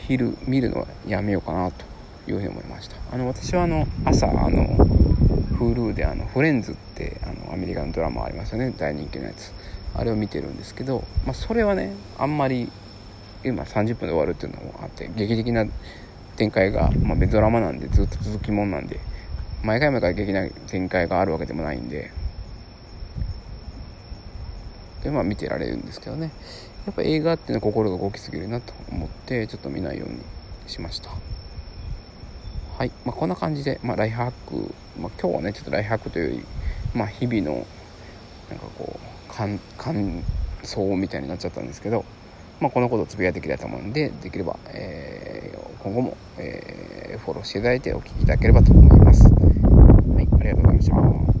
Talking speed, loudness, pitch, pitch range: 390 characters per minute, -22 LUFS, 100 Hz, 85-115 Hz